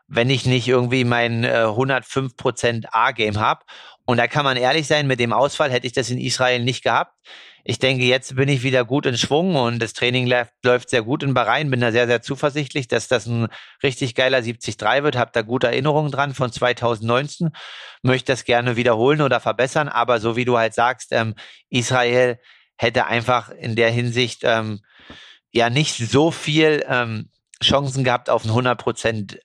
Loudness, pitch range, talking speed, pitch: -19 LUFS, 120-135 Hz, 185 wpm, 125 Hz